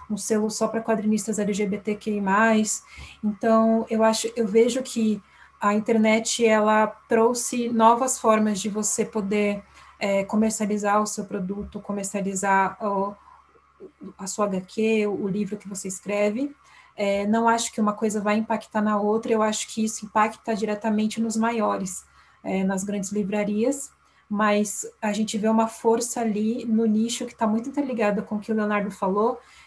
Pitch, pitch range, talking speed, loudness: 215 Hz, 205-225 Hz, 155 wpm, -24 LUFS